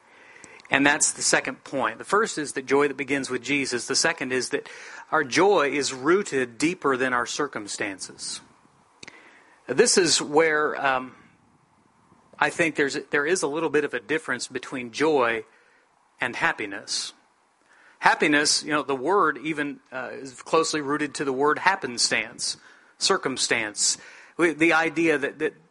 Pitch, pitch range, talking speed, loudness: 150 Hz, 135-165 Hz, 150 wpm, -23 LUFS